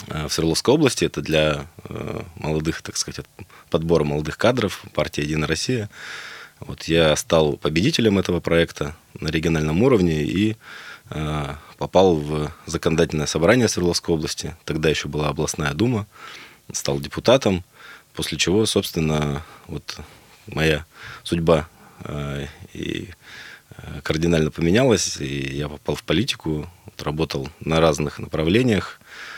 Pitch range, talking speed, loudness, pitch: 75-85 Hz, 110 wpm, -21 LUFS, 80 Hz